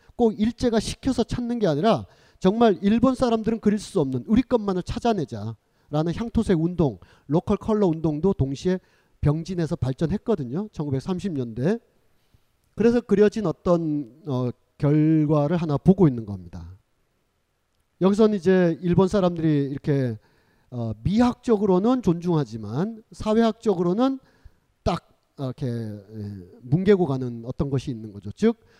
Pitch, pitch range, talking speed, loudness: 170 Hz, 130-210 Hz, 290 characters per minute, -23 LUFS